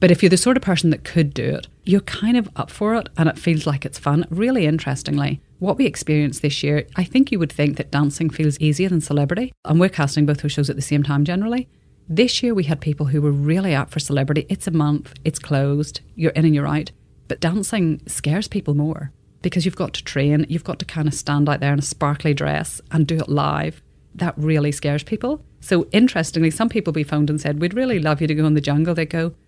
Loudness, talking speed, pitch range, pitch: -20 LUFS, 250 wpm, 145-180 Hz, 155 Hz